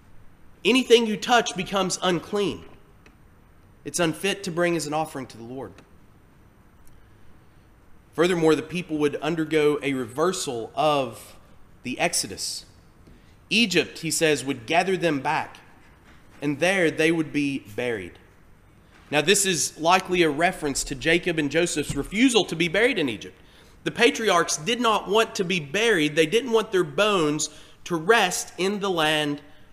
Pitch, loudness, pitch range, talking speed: 155 Hz, -23 LUFS, 130-185 Hz, 145 wpm